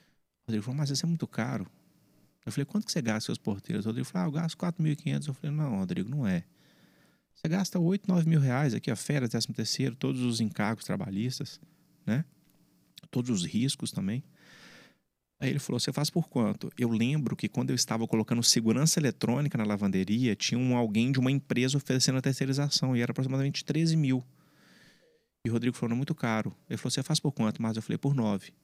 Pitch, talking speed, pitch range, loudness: 130 Hz, 210 wpm, 115-150 Hz, -30 LUFS